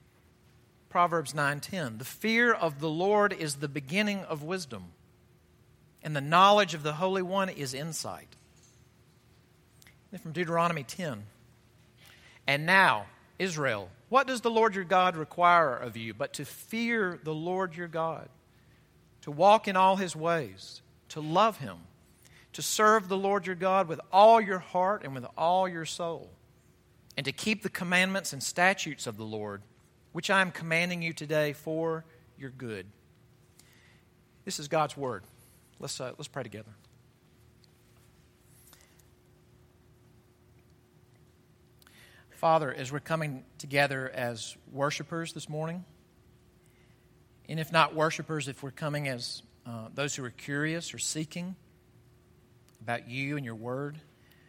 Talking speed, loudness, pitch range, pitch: 135 wpm, -29 LUFS, 125-180 Hz, 155 Hz